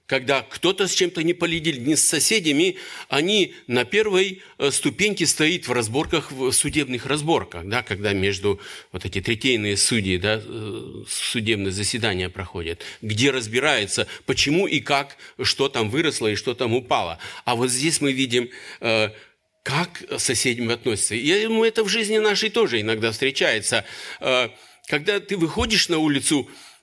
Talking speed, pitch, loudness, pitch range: 145 wpm, 135 Hz, -21 LUFS, 115-170 Hz